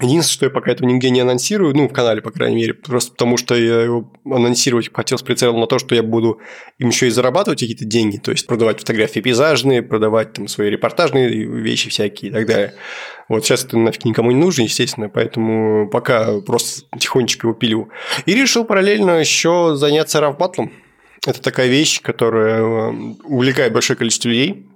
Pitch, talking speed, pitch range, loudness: 120 Hz, 185 wpm, 115-140 Hz, -16 LUFS